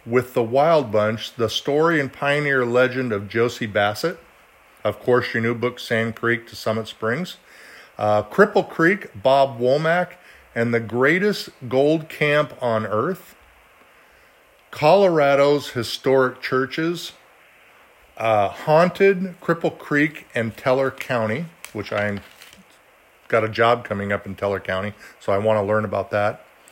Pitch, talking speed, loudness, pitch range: 125 Hz, 135 wpm, -21 LUFS, 110-150 Hz